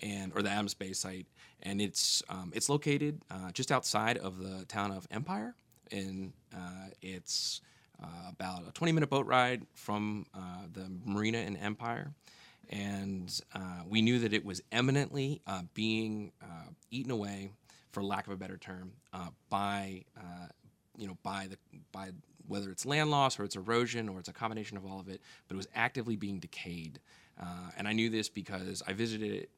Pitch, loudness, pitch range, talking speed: 100 Hz, -35 LUFS, 95-115 Hz, 185 wpm